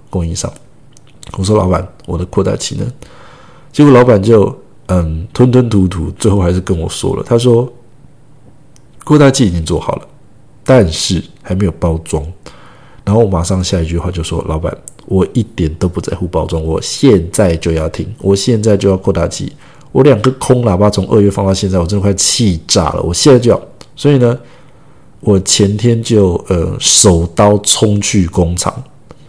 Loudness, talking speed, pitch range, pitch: -12 LUFS, 250 characters per minute, 90-125 Hz, 100 Hz